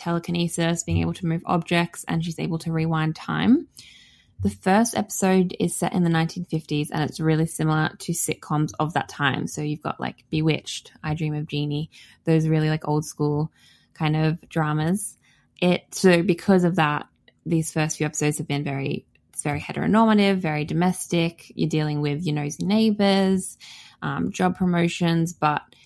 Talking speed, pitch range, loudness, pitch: 170 wpm, 150-175 Hz, -23 LUFS, 160 Hz